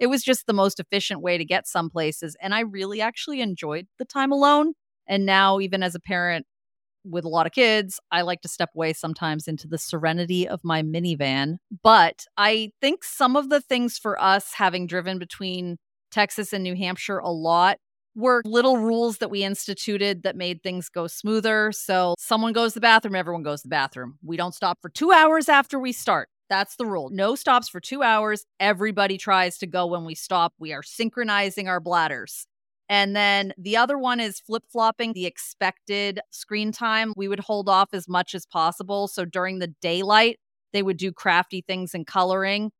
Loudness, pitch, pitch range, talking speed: -23 LUFS, 195 Hz, 175-220 Hz, 200 wpm